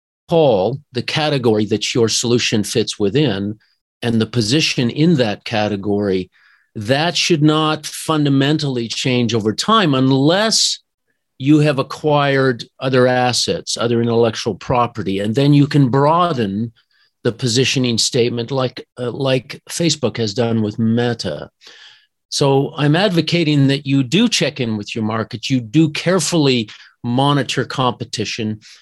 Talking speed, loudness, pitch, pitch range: 130 wpm, -16 LUFS, 130 Hz, 115-150 Hz